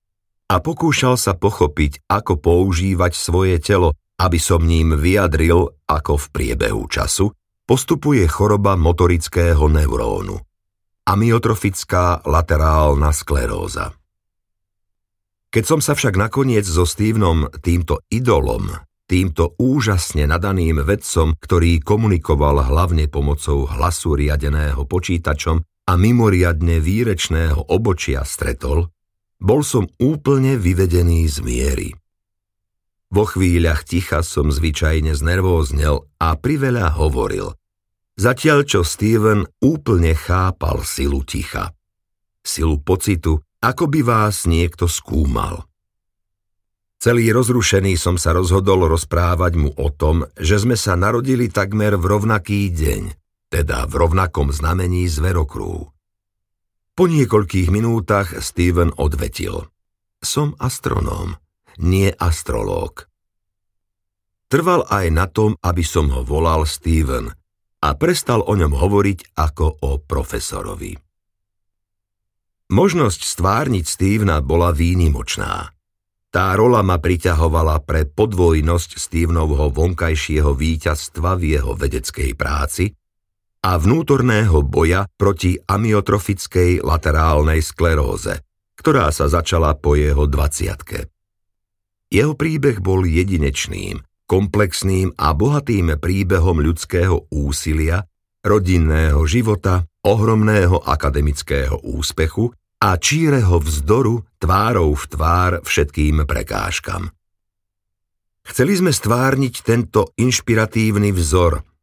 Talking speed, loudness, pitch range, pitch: 100 wpm, -17 LUFS, 80-100 Hz, 90 Hz